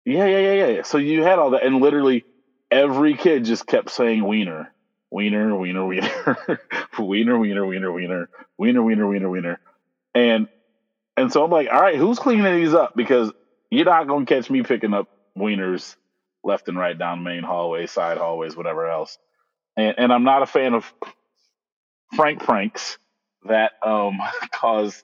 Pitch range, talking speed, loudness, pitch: 95-140 Hz, 170 wpm, -20 LUFS, 110 Hz